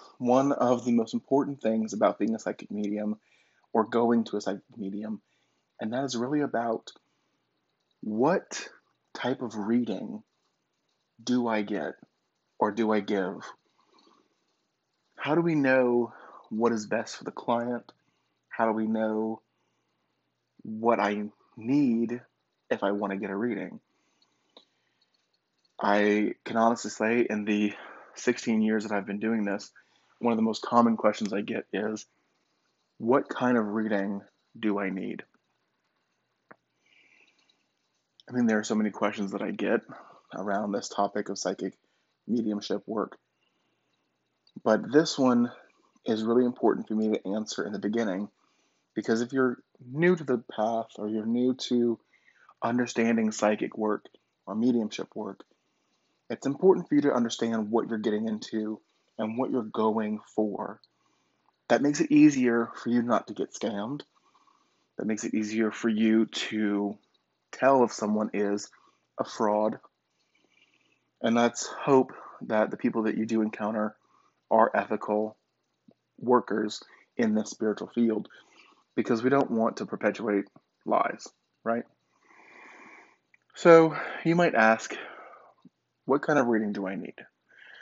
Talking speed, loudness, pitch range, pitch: 140 wpm, -28 LUFS, 105-120 Hz, 110 Hz